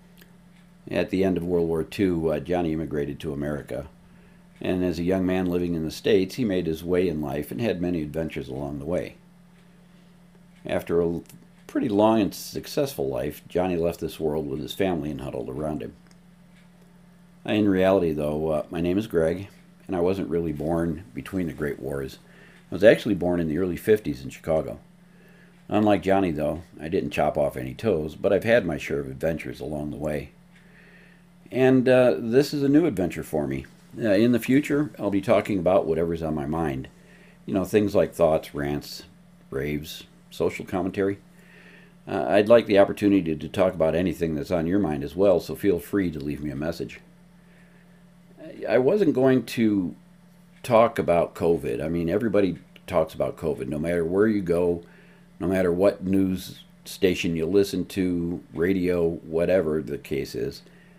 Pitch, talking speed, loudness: 95 Hz, 180 wpm, -25 LUFS